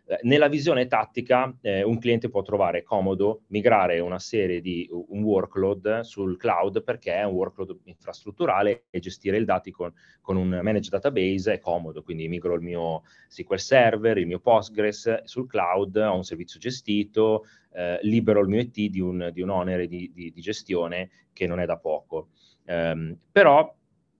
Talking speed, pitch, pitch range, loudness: 170 wpm, 100 Hz, 90-110 Hz, -25 LUFS